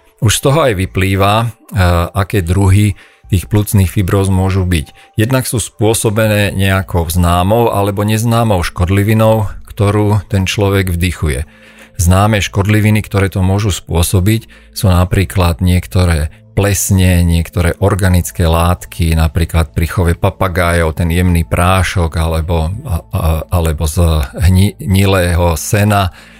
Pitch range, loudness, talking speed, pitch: 85-105 Hz, -13 LUFS, 115 wpm, 95 Hz